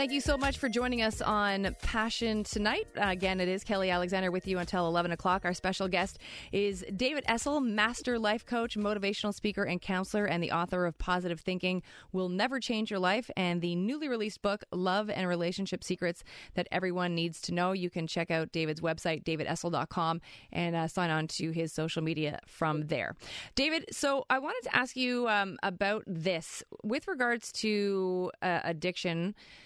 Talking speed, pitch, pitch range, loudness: 180 wpm, 185 Hz, 175-215 Hz, -32 LUFS